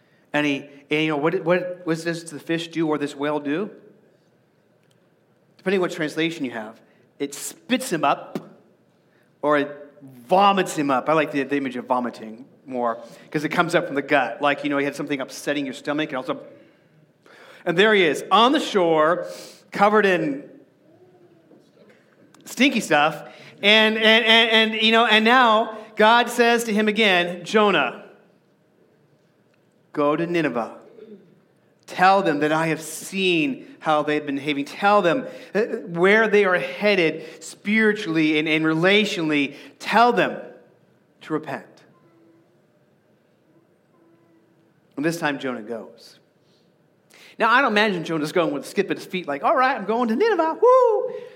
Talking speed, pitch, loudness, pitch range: 155 wpm, 170 Hz, -20 LUFS, 150-215 Hz